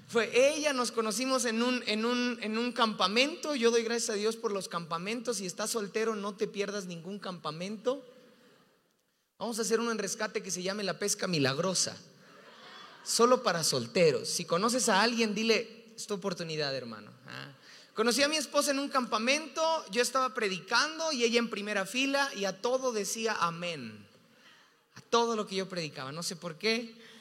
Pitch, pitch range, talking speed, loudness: 225 Hz, 195-245 Hz, 175 wpm, -30 LUFS